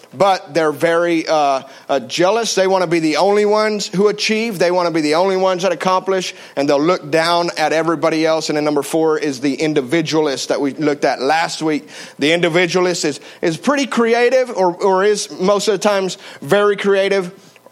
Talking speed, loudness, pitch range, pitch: 200 wpm, -16 LUFS, 155-195 Hz, 180 Hz